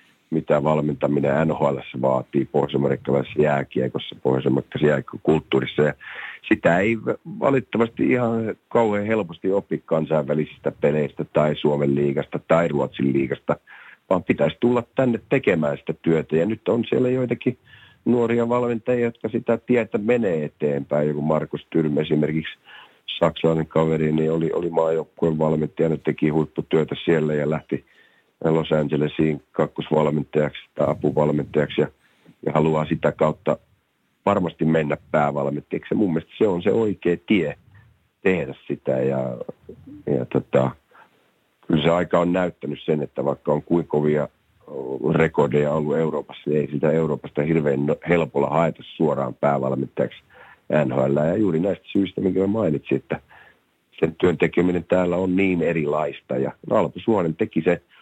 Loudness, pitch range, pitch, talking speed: -22 LUFS, 75-95 Hz, 80 Hz, 130 wpm